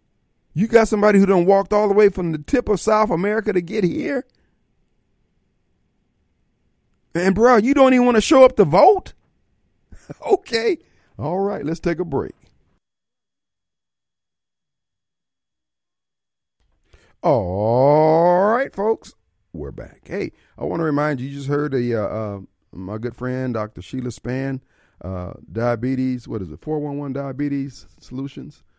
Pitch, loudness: 145 Hz, -19 LUFS